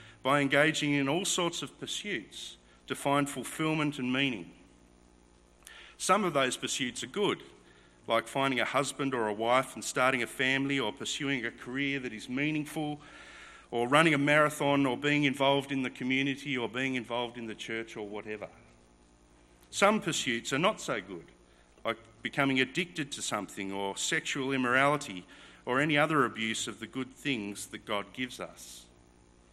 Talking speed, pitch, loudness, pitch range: 165 wpm, 125 Hz, -30 LUFS, 105-140 Hz